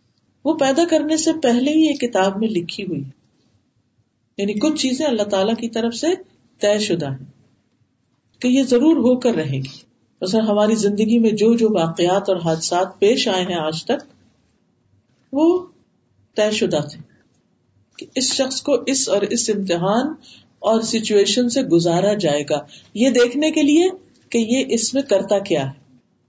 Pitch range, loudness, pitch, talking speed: 170-260 Hz, -19 LUFS, 215 Hz, 165 wpm